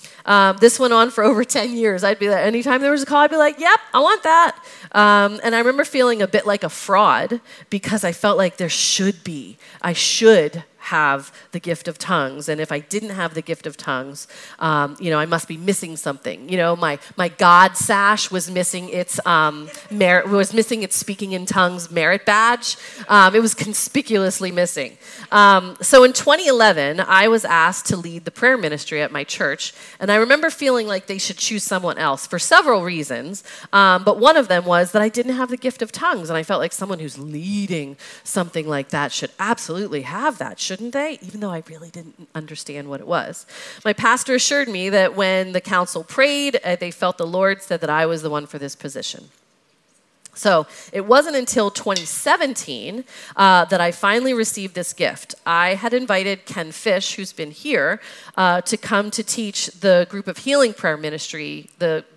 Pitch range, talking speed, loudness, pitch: 170-225 Hz, 205 wpm, -17 LUFS, 195 Hz